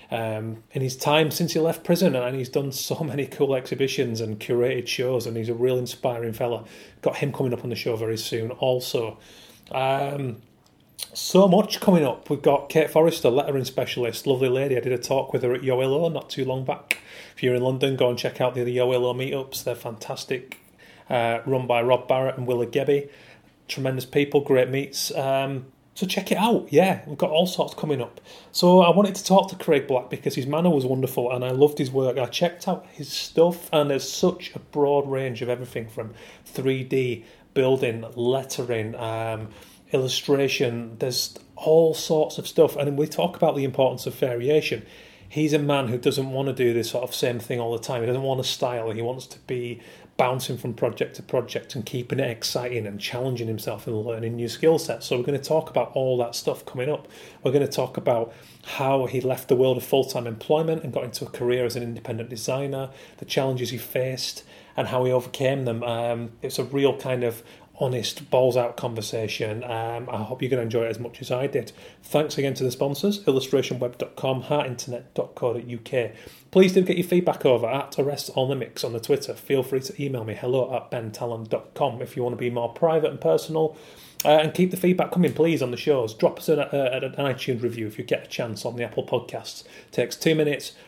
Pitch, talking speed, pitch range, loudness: 130 Hz, 210 wpm, 120-145 Hz, -24 LUFS